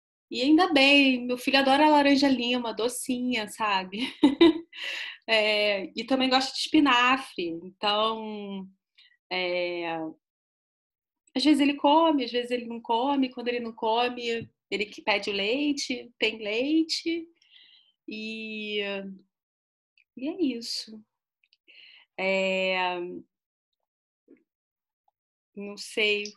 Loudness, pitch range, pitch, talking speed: -25 LUFS, 205-280 Hz, 240 Hz, 100 wpm